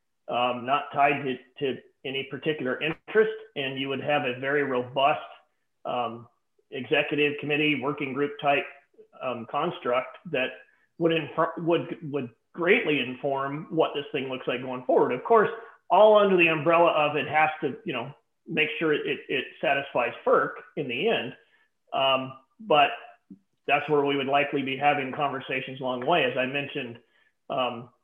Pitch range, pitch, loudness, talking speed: 135-160 Hz, 145 Hz, -26 LUFS, 160 wpm